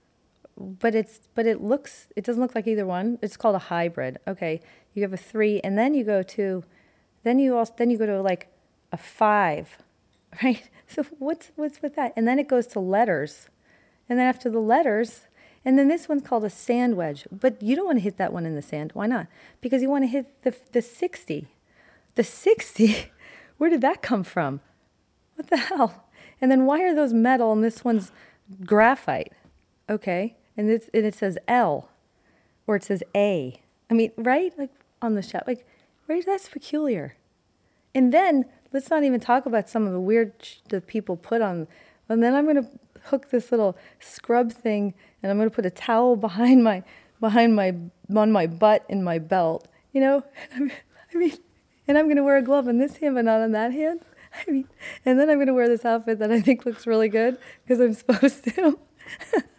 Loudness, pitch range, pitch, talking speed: -23 LUFS, 210-270 Hz, 235 Hz, 205 wpm